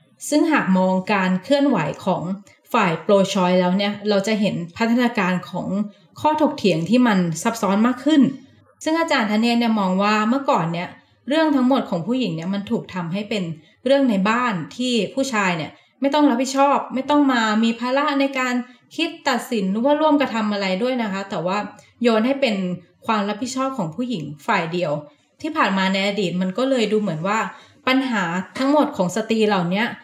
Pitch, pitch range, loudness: 220 Hz, 190-260 Hz, -20 LUFS